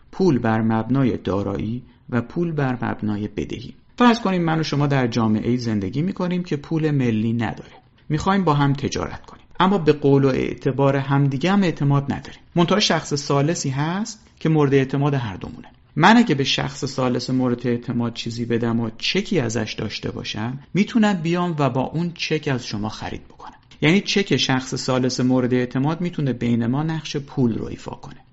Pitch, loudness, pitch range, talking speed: 140 Hz, -21 LUFS, 120-160 Hz, 180 wpm